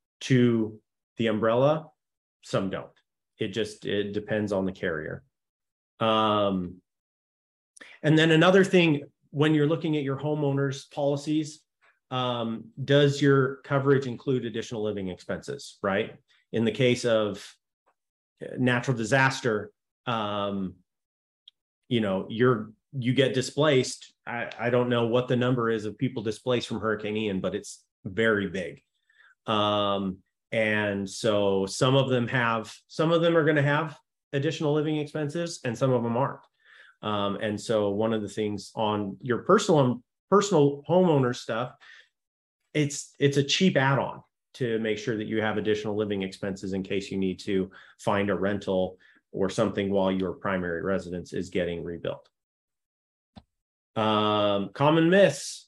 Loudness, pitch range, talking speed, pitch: -26 LUFS, 105-140 Hz, 145 wpm, 115 Hz